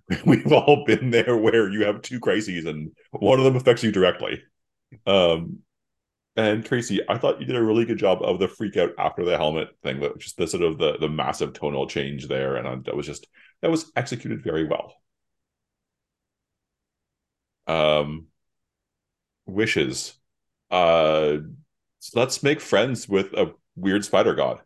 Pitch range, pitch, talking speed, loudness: 85-130 Hz, 110 Hz, 165 wpm, -23 LUFS